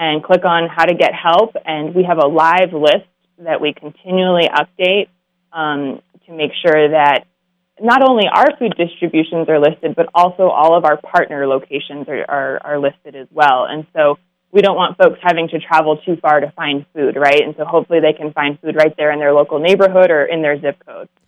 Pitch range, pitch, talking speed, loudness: 150-180 Hz, 160 Hz, 210 wpm, -14 LUFS